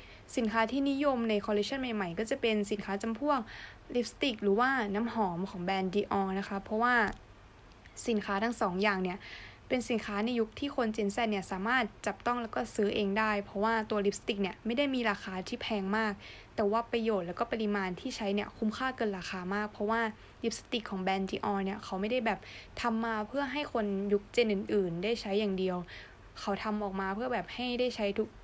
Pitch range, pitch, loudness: 200-235 Hz, 215 Hz, -33 LUFS